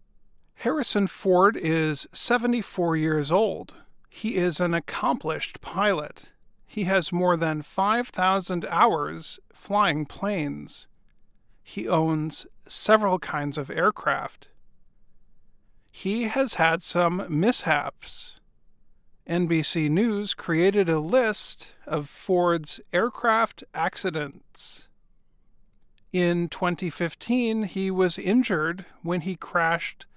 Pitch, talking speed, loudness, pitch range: 180 Hz, 95 wpm, -25 LUFS, 165-205 Hz